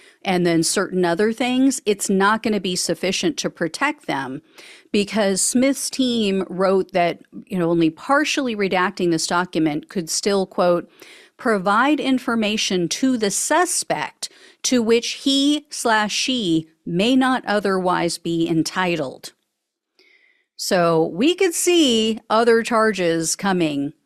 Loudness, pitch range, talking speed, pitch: -19 LUFS, 180-270 Hz, 125 wpm, 210 Hz